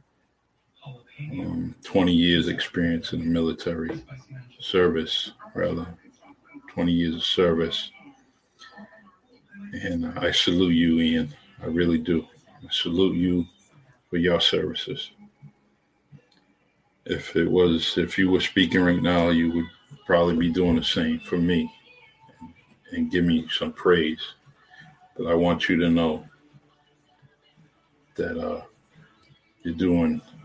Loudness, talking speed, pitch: -24 LUFS, 120 wpm, 90 Hz